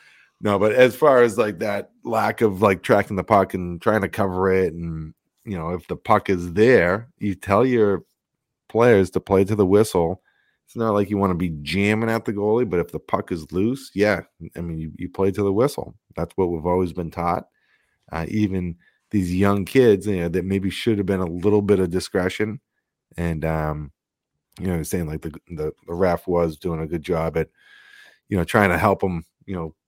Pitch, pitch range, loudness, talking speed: 95 Hz, 85-105 Hz, -21 LUFS, 215 wpm